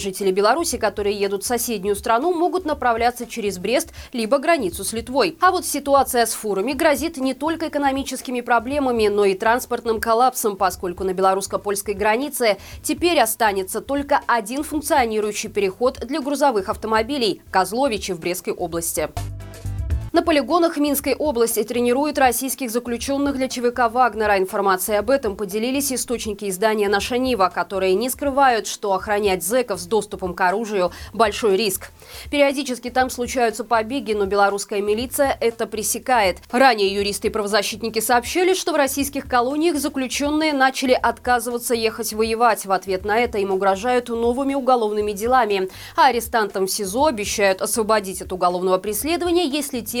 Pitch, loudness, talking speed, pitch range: 235 Hz, -20 LUFS, 145 wpm, 205-270 Hz